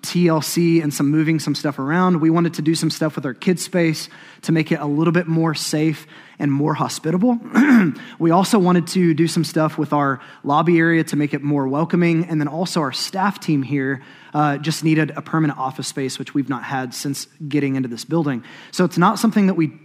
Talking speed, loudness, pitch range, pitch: 220 wpm, -19 LUFS, 145-170 Hz, 160 Hz